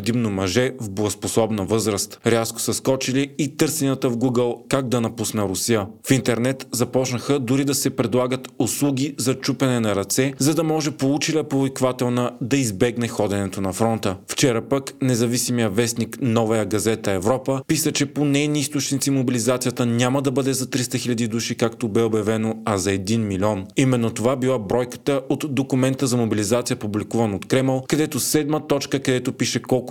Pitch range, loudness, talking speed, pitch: 115-135 Hz, -21 LUFS, 165 wpm, 125 Hz